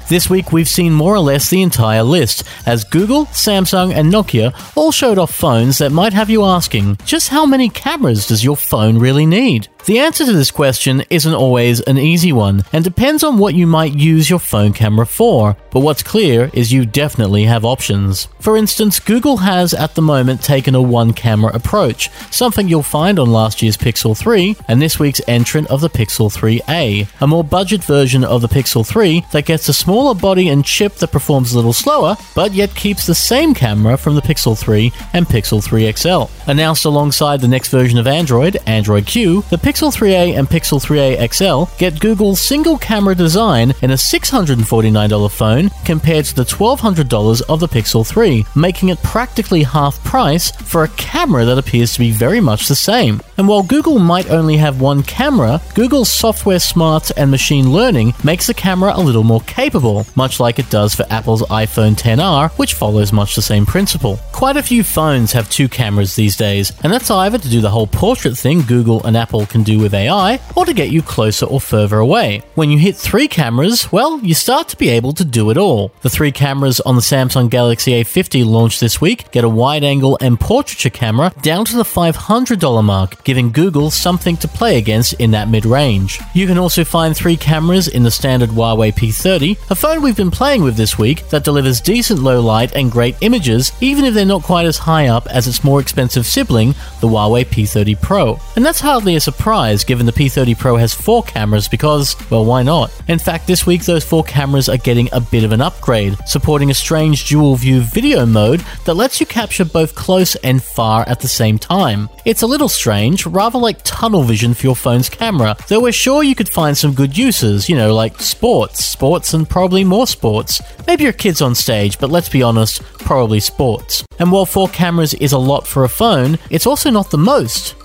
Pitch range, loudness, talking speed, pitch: 115-180 Hz, -12 LUFS, 205 wpm, 140 Hz